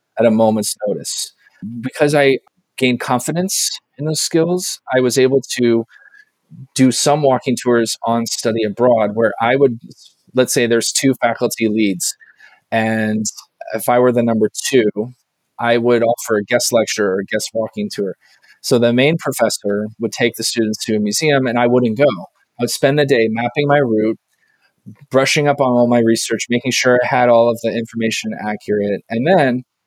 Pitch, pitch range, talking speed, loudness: 120 Hz, 110-135 Hz, 180 wpm, -16 LUFS